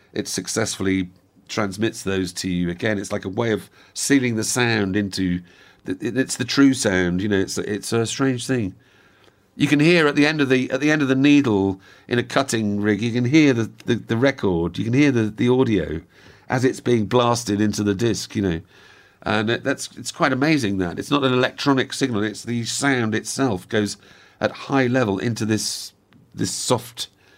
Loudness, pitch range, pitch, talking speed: -21 LUFS, 100-130 Hz, 115 Hz, 205 wpm